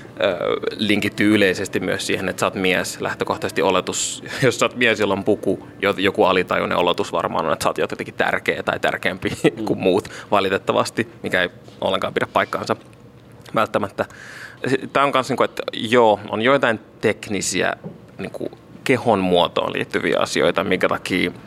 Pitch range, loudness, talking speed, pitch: 95-105 Hz, -20 LUFS, 145 wpm, 100 Hz